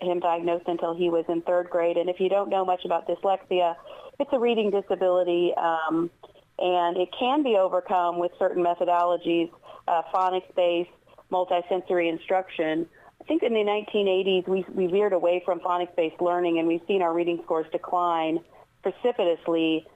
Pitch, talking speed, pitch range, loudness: 175 Hz, 160 wpm, 170-190 Hz, -25 LUFS